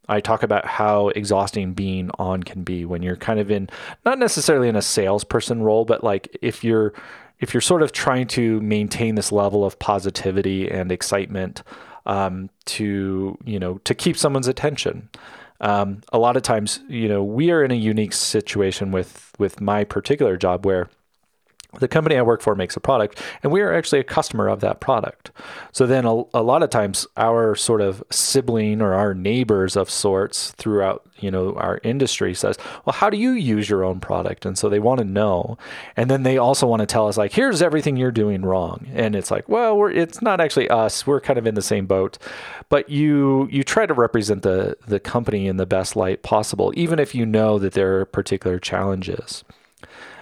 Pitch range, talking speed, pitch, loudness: 95-125 Hz, 205 wpm, 105 Hz, -20 LUFS